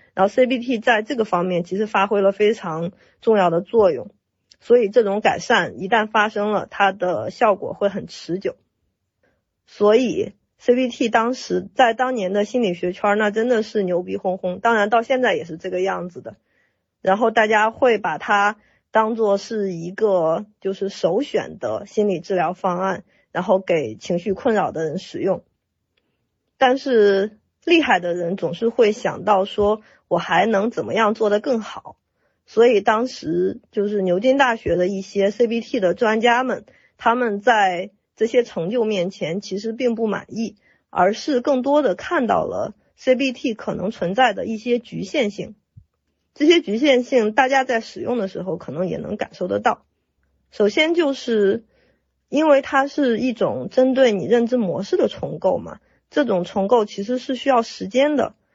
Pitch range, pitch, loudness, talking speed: 195-250 Hz, 215 Hz, -20 LUFS, 250 characters per minute